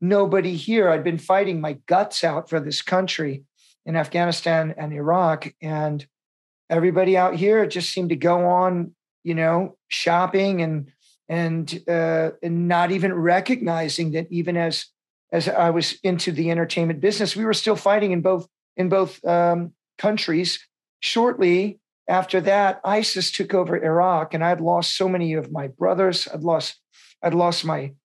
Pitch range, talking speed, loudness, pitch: 165-185 Hz, 160 wpm, -21 LUFS, 175 Hz